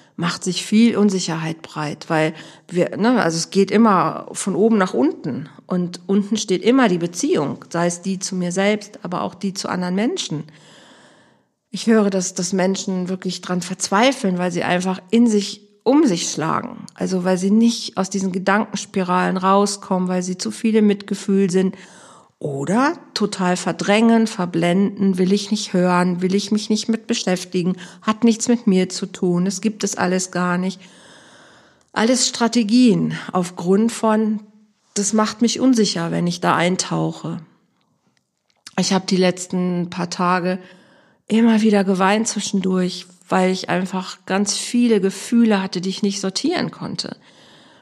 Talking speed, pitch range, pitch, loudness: 155 wpm, 180-215 Hz, 195 Hz, -19 LUFS